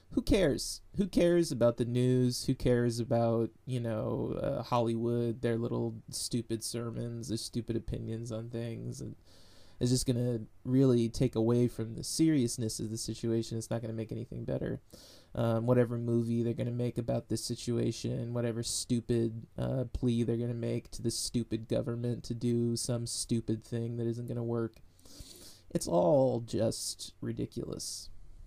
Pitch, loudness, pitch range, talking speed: 115 Hz, -33 LUFS, 115-120 Hz, 170 wpm